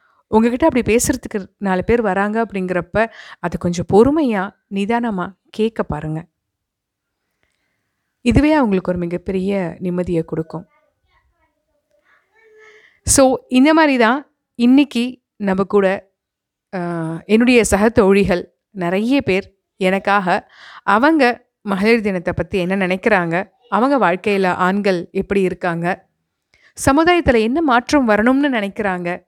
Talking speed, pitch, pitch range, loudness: 95 wpm, 205 Hz, 185-255 Hz, -17 LUFS